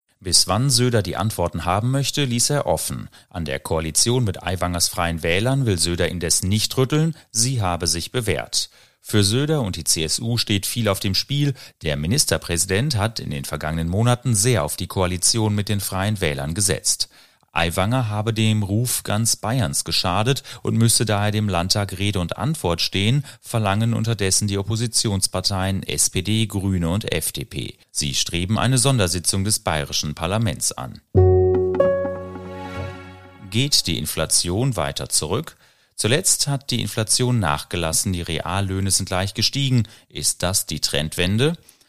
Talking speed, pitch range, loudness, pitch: 150 wpm, 90-120 Hz, -20 LUFS, 100 Hz